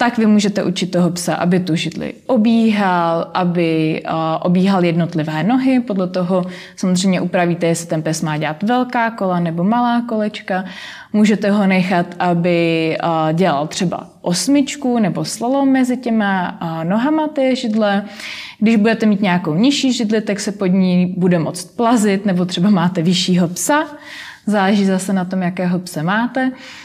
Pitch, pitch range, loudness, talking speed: 190 Hz, 175-225 Hz, -16 LUFS, 150 wpm